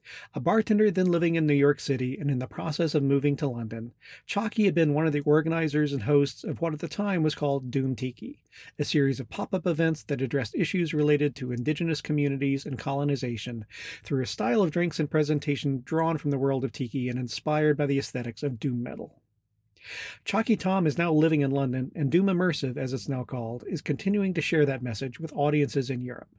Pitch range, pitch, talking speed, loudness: 135-165 Hz, 145 Hz, 215 wpm, -27 LUFS